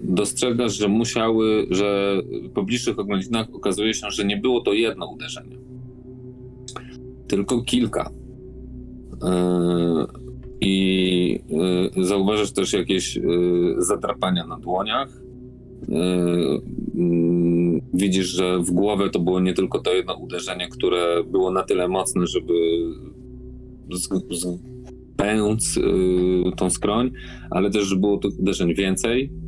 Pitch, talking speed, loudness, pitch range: 95 Hz, 105 wpm, -22 LUFS, 90-120 Hz